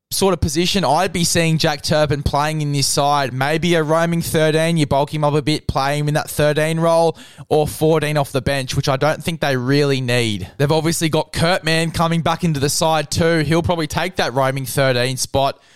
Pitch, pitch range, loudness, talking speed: 150 Hz, 140-165 Hz, -17 LUFS, 220 wpm